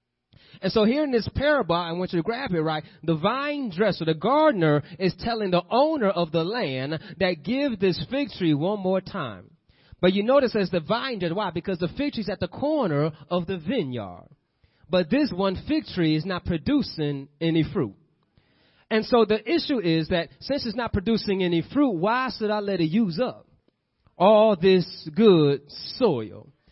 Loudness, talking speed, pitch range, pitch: -24 LUFS, 190 wpm, 165-230 Hz, 190 Hz